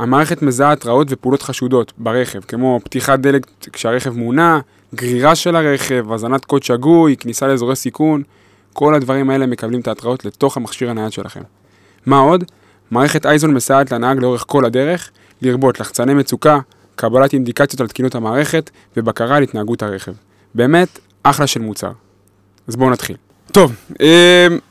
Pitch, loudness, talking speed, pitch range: 130 Hz, -14 LUFS, 150 wpm, 115-140 Hz